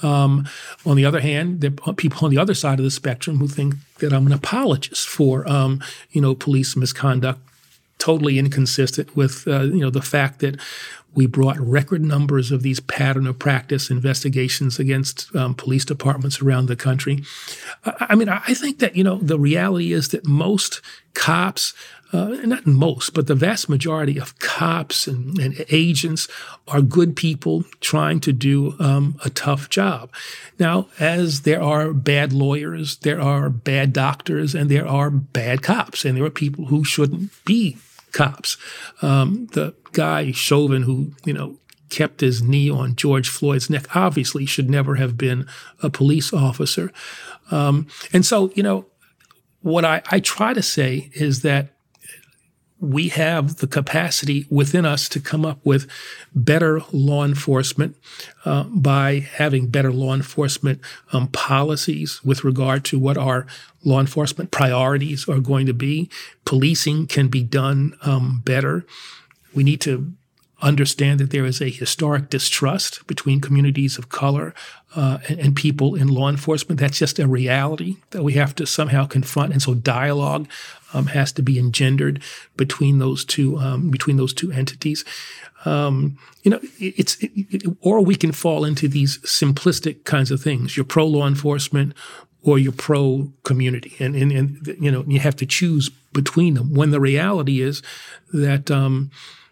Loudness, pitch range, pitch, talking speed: -19 LUFS, 135-155 Hz, 140 Hz, 165 wpm